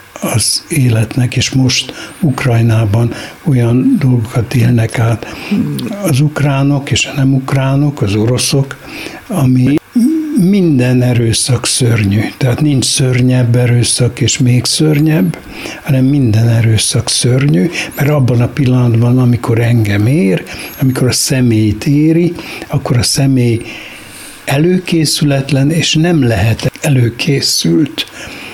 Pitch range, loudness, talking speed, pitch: 120-150 Hz, -11 LUFS, 105 wpm, 130 Hz